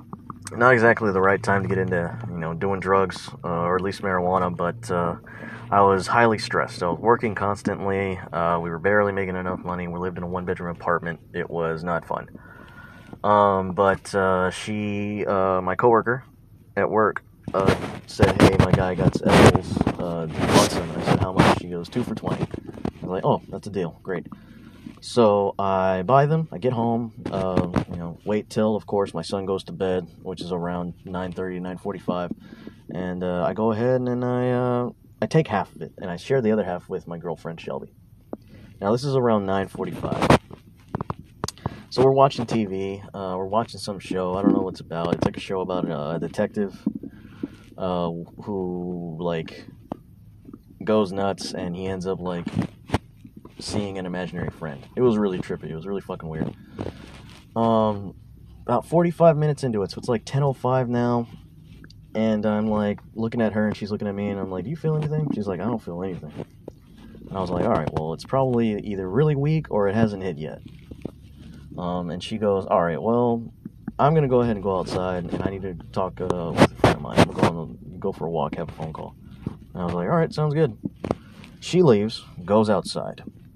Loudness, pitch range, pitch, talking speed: -23 LUFS, 90-115 Hz, 100 Hz, 205 wpm